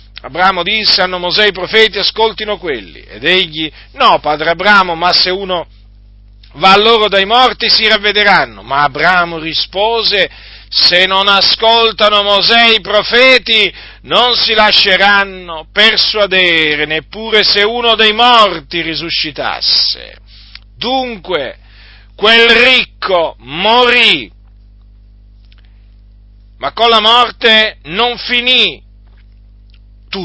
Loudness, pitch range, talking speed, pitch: -9 LUFS, 140-220 Hz, 105 wpm, 190 Hz